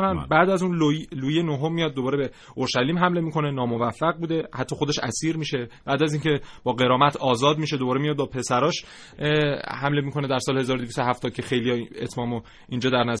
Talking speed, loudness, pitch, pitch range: 180 wpm, -24 LUFS, 140 Hz, 125-155 Hz